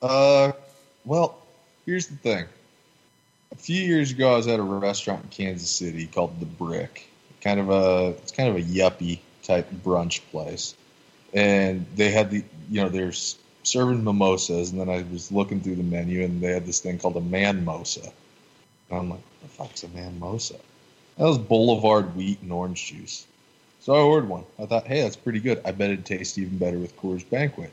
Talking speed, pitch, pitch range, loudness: 195 wpm, 100 Hz, 90-115 Hz, -24 LUFS